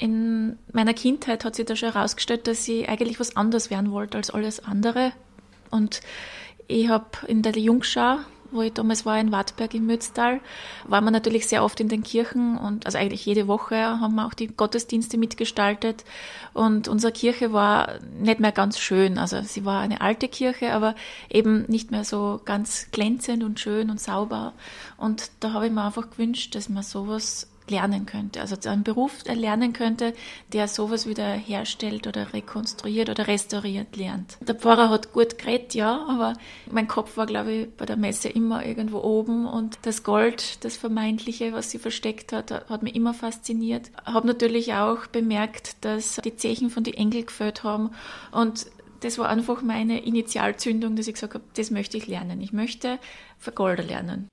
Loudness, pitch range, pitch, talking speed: -25 LUFS, 215-230 Hz, 225 Hz, 180 wpm